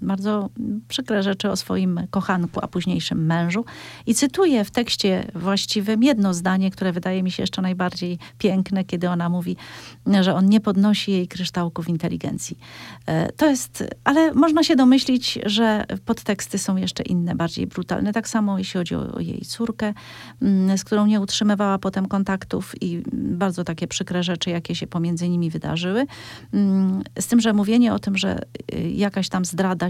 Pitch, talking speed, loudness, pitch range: 195 Hz, 160 wpm, -22 LUFS, 180-215 Hz